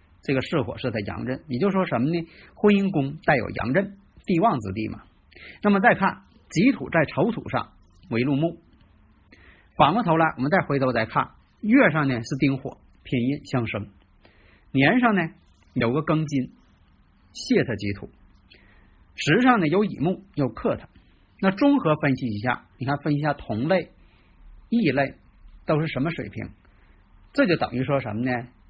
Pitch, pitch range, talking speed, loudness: 130 Hz, 105-160 Hz, 230 characters per minute, -24 LUFS